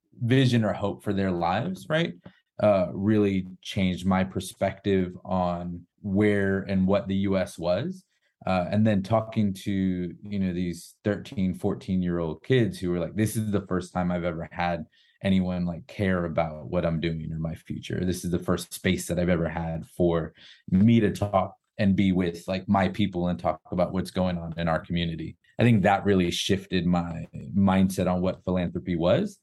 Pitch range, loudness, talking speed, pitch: 90-100 Hz, -26 LUFS, 185 wpm, 95 Hz